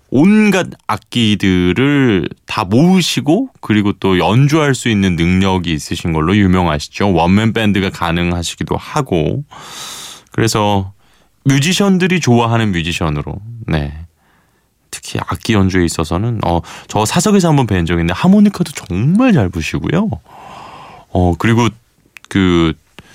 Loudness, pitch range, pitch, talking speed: -14 LUFS, 85-135 Hz, 100 Hz, 275 characters per minute